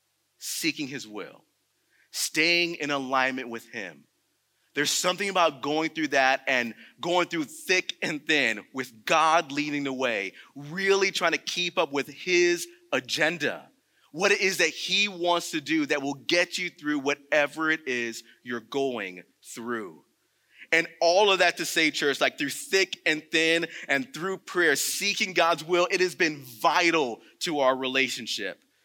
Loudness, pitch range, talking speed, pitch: -25 LUFS, 140-185 Hz, 160 wpm, 165 Hz